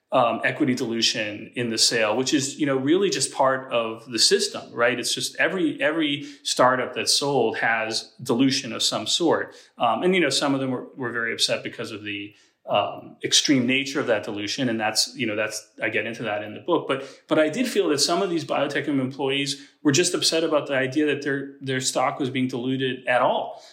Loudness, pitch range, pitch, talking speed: -23 LUFS, 115-145 Hz, 135 Hz, 220 wpm